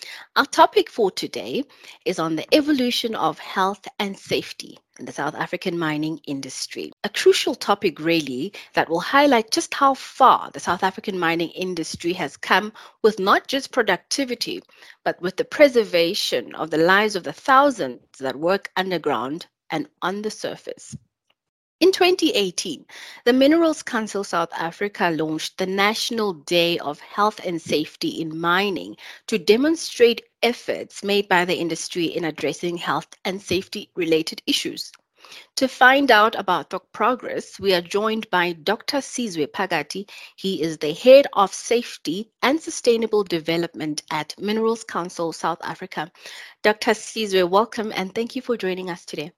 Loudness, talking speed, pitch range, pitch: -21 LUFS, 150 wpm, 170-245 Hz, 200 Hz